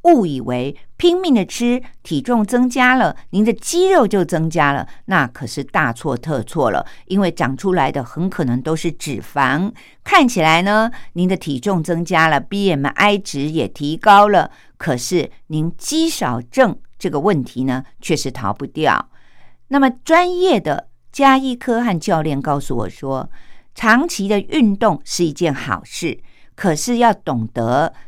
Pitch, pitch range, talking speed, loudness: 175 Hz, 140-230 Hz, 225 characters per minute, -17 LUFS